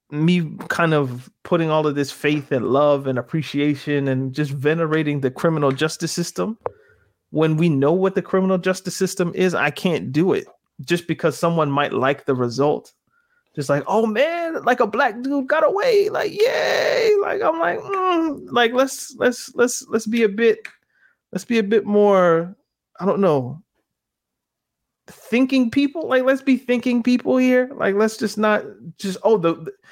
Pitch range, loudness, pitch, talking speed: 155-255 Hz, -20 LUFS, 195 Hz, 175 wpm